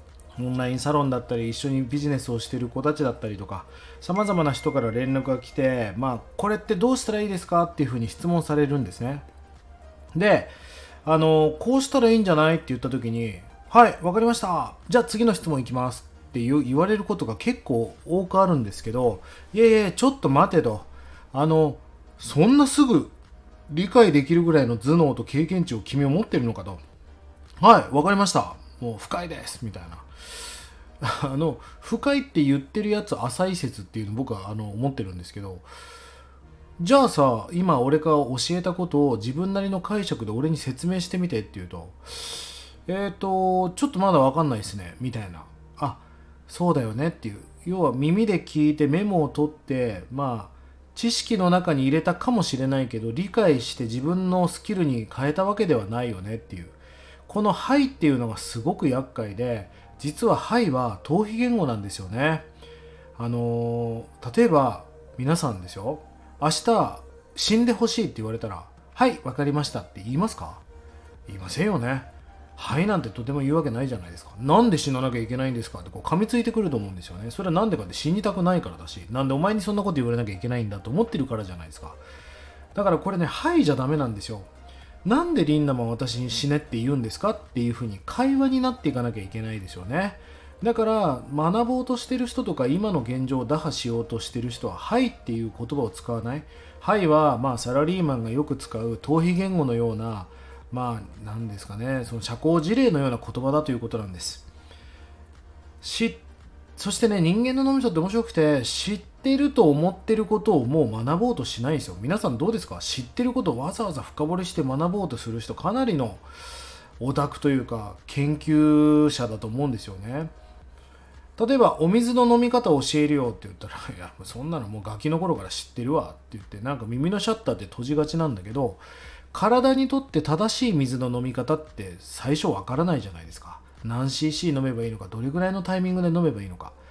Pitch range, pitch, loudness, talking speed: 110-175 Hz, 135 Hz, -24 LUFS, 390 characters per minute